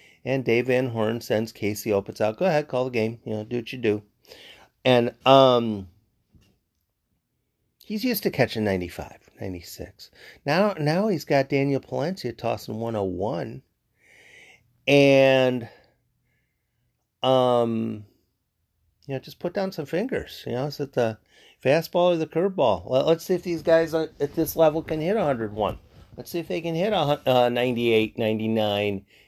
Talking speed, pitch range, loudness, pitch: 150 wpm, 105-150 Hz, -24 LUFS, 125 Hz